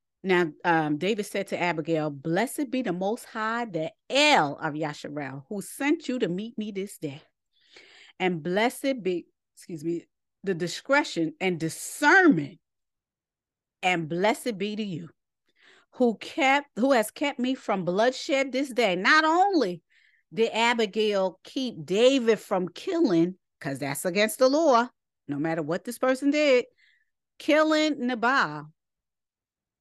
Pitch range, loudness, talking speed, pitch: 175-270 Hz, -25 LUFS, 135 wpm, 215 Hz